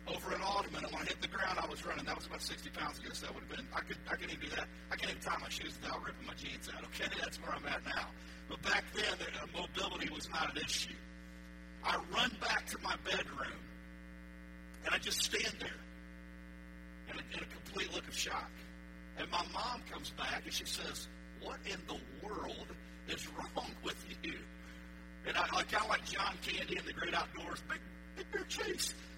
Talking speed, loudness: 215 wpm, -40 LUFS